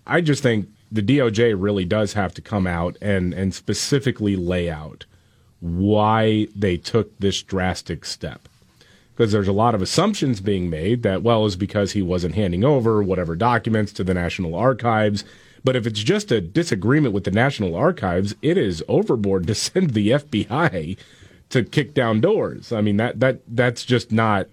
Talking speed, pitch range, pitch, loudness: 175 wpm, 95-120 Hz, 105 Hz, -21 LUFS